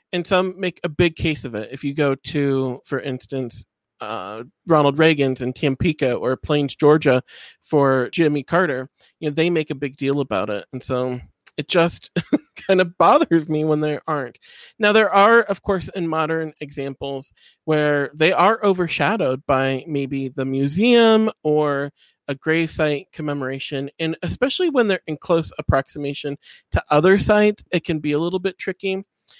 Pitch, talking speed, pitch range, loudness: 150 Hz, 170 wpm, 135-175 Hz, -20 LUFS